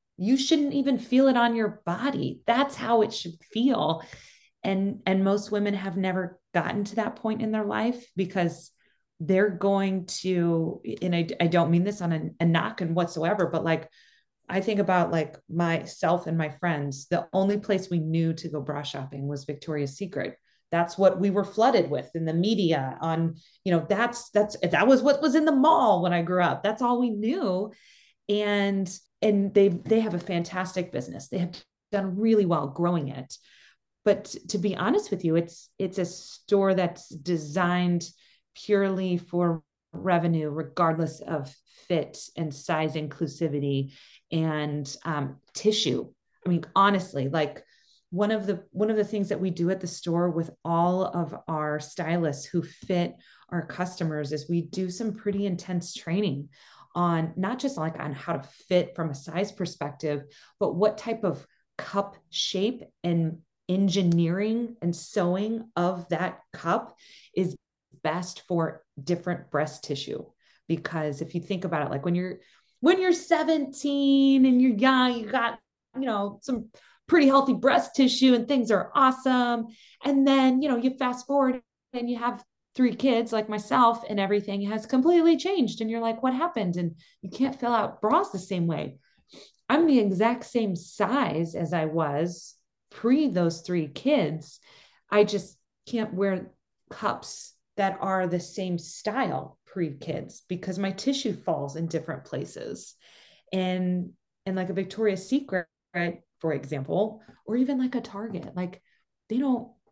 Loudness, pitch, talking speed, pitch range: -26 LUFS, 185 Hz, 165 wpm, 165-220 Hz